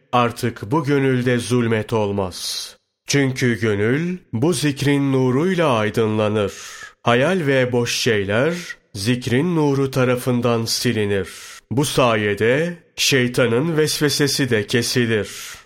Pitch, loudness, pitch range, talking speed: 125 Hz, -19 LUFS, 115-140 Hz, 95 wpm